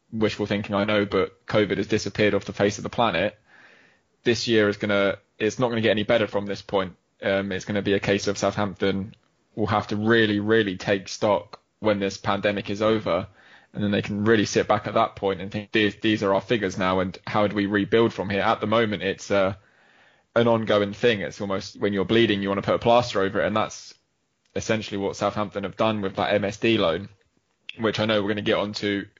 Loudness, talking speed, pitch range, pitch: -24 LUFS, 230 wpm, 100-110 Hz, 105 Hz